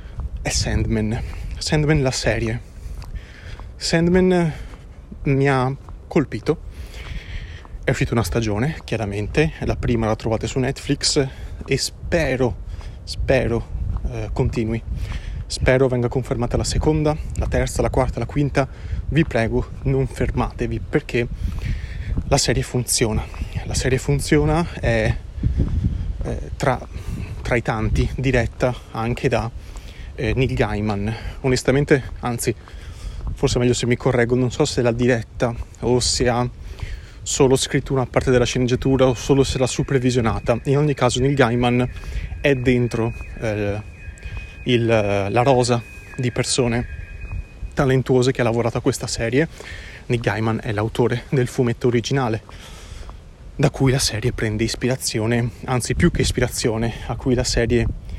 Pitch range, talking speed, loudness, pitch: 100-130 Hz, 130 wpm, -21 LUFS, 120 Hz